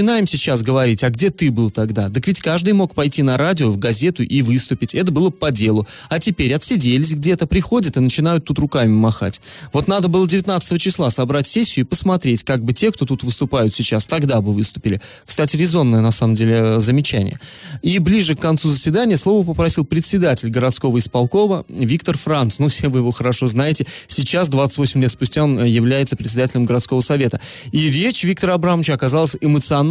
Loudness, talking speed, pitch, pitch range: -16 LUFS, 185 wpm, 140 Hz, 125-170 Hz